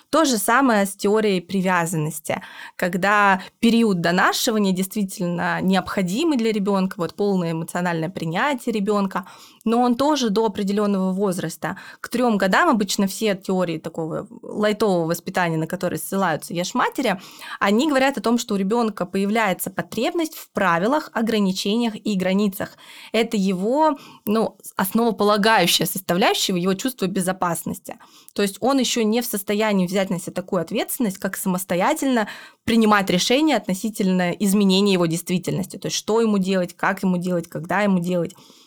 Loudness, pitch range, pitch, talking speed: -21 LUFS, 185-225 Hz, 200 Hz, 140 wpm